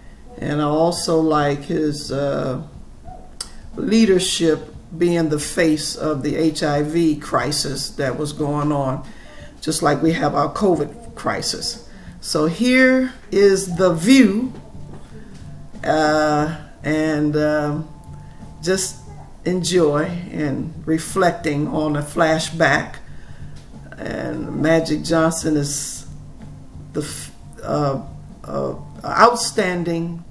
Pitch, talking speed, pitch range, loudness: 155 Hz, 95 wpm, 150-175 Hz, -19 LUFS